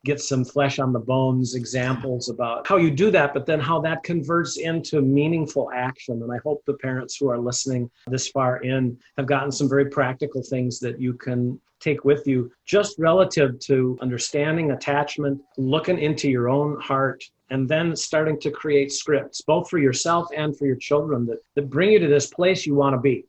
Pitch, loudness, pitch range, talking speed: 140 Hz, -22 LUFS, 130-150 Hz, 200 wpm